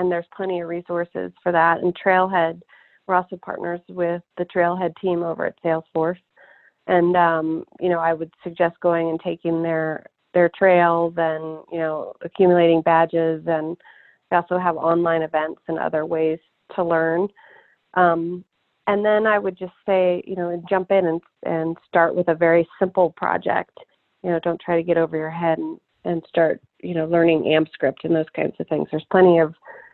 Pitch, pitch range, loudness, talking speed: 170 Hz, 165-180 Hz, -21 LUFS, 185 wpm